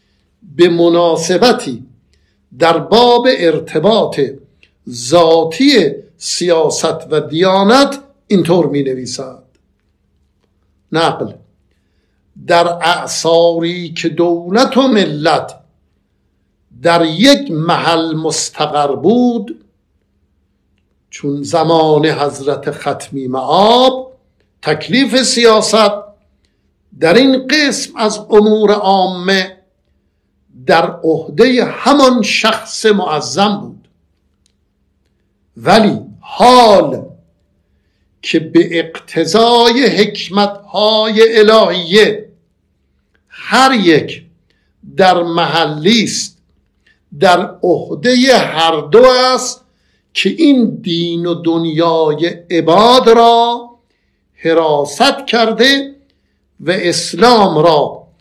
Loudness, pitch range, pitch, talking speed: -11 LUFS, 155-225 Hz, 170 Hz, 75 wpm